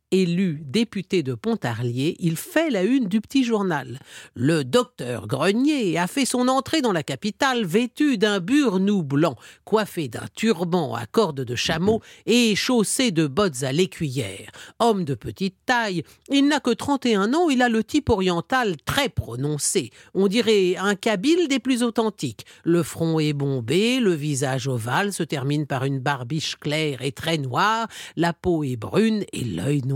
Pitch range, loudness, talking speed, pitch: 145-225 Hz, -22 LUFS, 170 wpm, 185 Hz